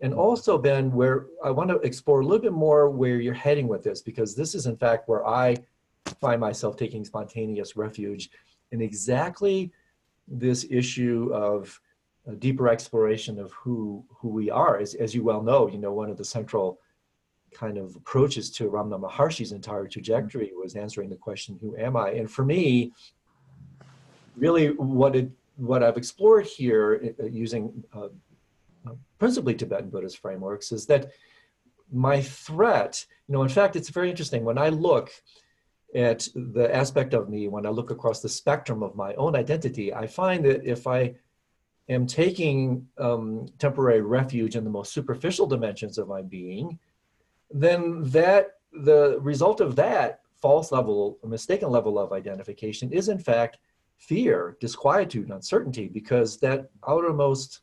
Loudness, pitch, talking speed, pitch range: -25 LUFS, 125 Hz, 160 wpm, 110-145 Hz